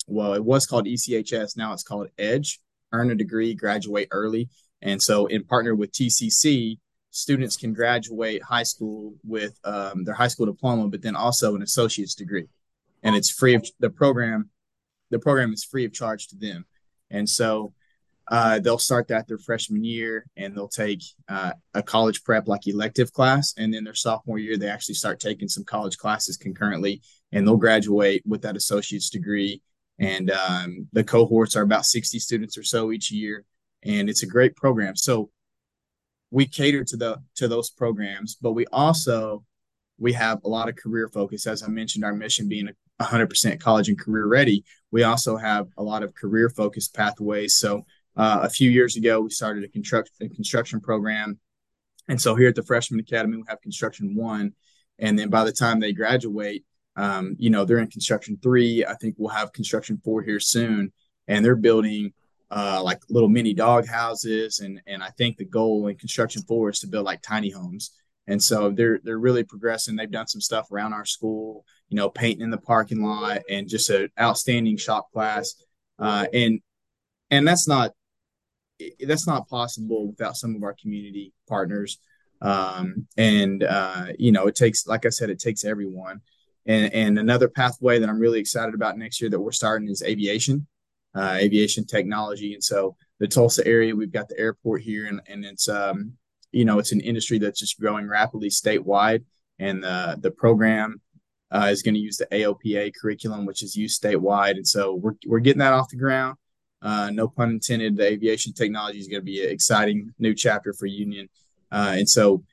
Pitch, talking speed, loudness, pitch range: 110 Hz, 190 wpm, -23 LUFS, 105-115 Hz